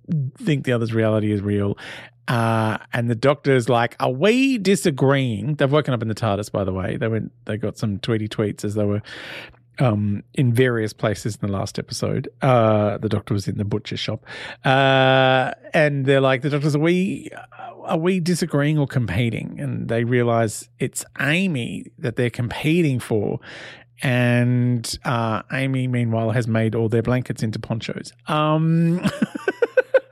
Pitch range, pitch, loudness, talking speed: 110-145 Hz, 125 Hz, -21 LUFS, 165 wpm